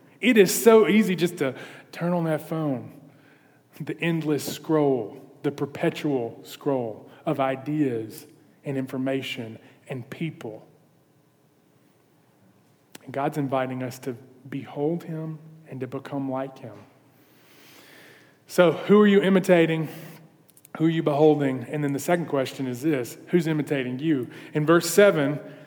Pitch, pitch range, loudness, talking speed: 145 Hz, 135-160 Hz, -24 LUFS, 130 wpm